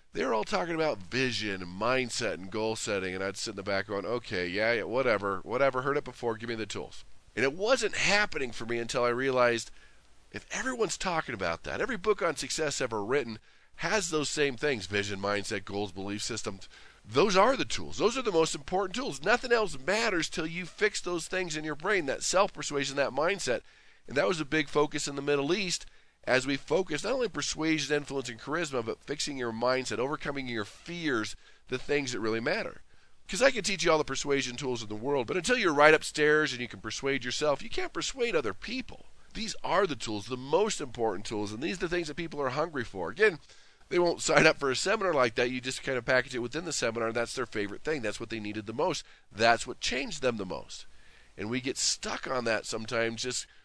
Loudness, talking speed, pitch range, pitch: -30 LUFS, 225 wpm, 115-165 Hz, 140 Hz